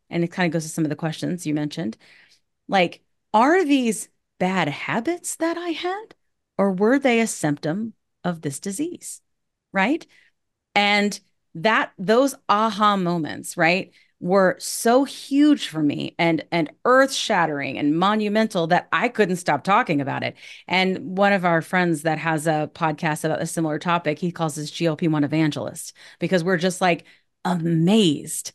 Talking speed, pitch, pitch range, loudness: 160 wpm, 180 Hz, 160-220 Hz, -22 LUFS